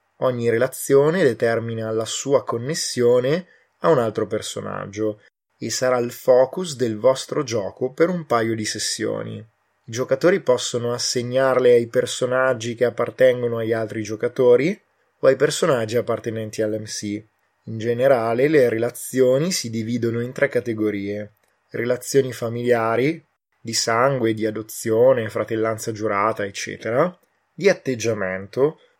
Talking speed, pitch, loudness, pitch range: 120 wpm, 120 Hz, -21 LUFS, 110-130 Hz